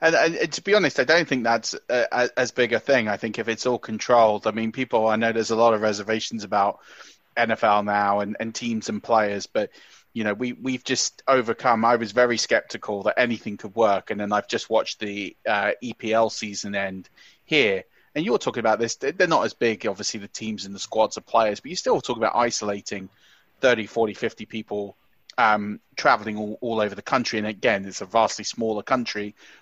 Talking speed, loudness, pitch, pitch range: 215 wpm, -23 LUFS, 110 Hz, 105-115 Hz